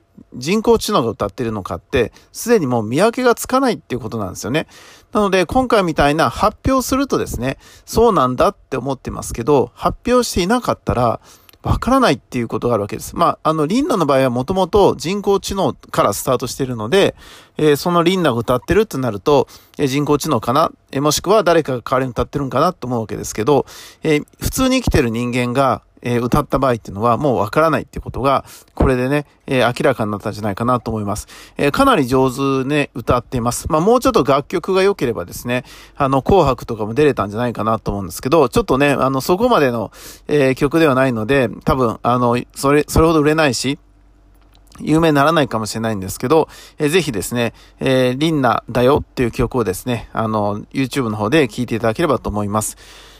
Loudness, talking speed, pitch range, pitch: -17 LUFS, 460 characters per minute, 115-160 Hz, 135 Hz